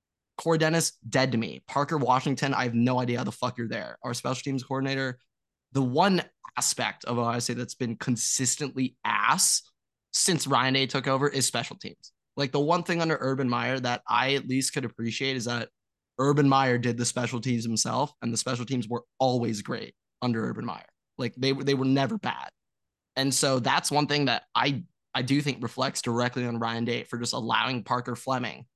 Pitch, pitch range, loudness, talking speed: 130 Hz, 120-135 Hz, -27 LUFS, 200 wpm